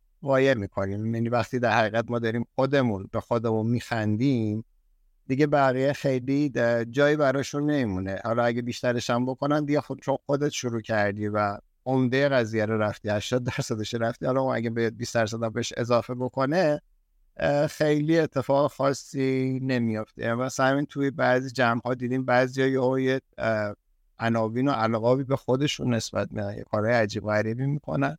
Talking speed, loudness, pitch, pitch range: 140 wpm, -26 LUFS, 125 Hz, 110-135 Hz